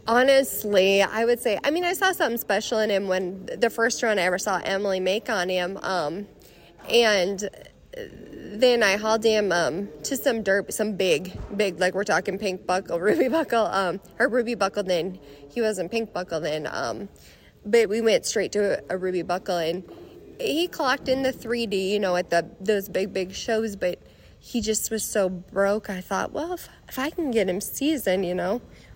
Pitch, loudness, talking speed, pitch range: 205 Hz, -24 LUFS, 195 wpm, 185-235 Hz